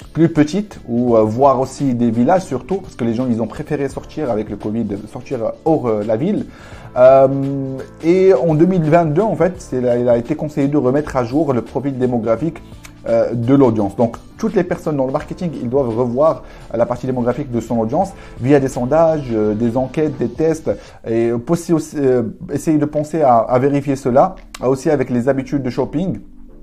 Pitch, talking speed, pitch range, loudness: 135 Hz, 195 wpm, 120-155 Hz, -17 LUFS